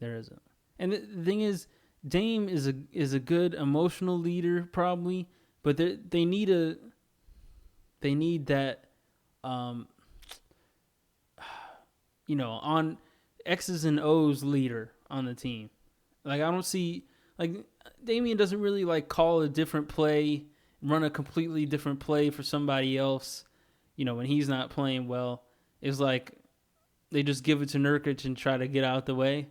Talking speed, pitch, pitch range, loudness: 155 wpm, 150 Hz, 135-170 Hz, -30 LUFS